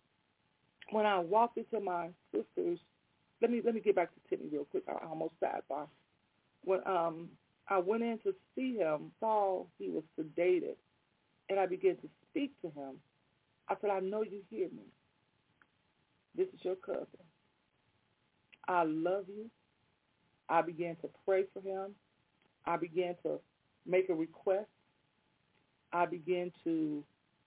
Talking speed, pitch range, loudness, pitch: 150 wpm, 170-220 Hz, -36 LUFS, 190 Hz